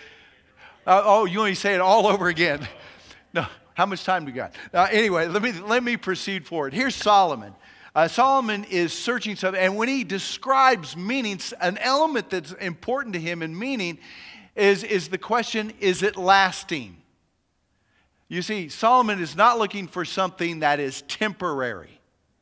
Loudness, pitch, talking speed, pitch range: -23 LUFS, 195 Hz, 165 wpm, 175-220 Hz